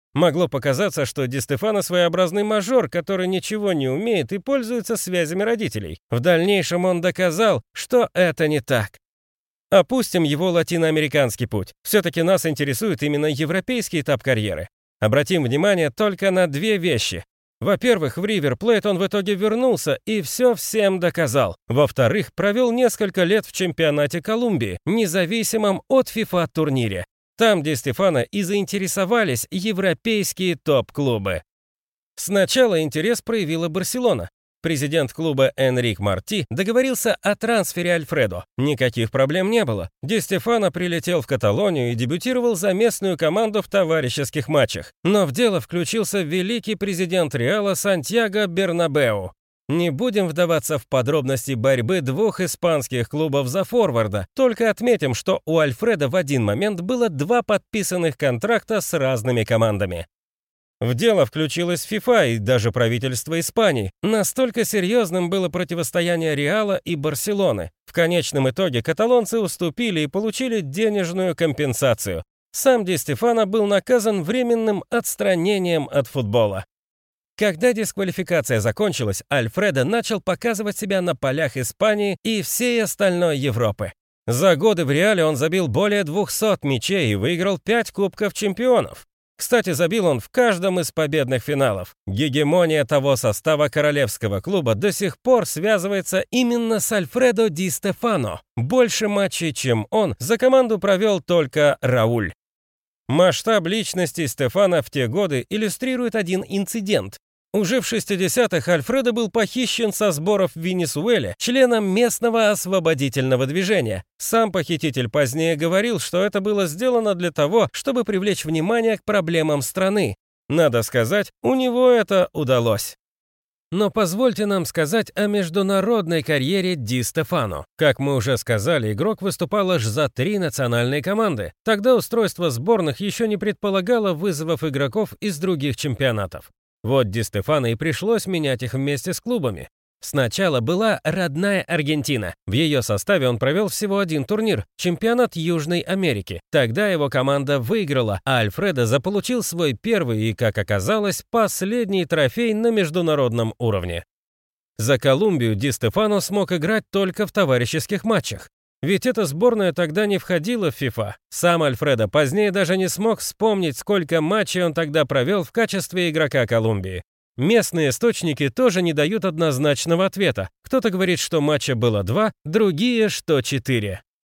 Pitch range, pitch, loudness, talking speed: 145-210 Hz, 180 Hz, -20 LUFS, 135 wpm